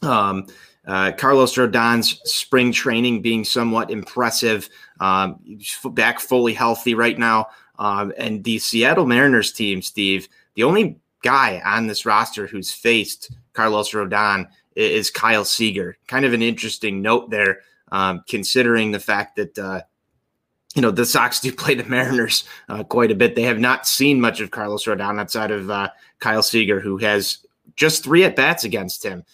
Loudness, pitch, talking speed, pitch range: -18 LUFS, 110 Hz, 165 wpm, 100-120 Hz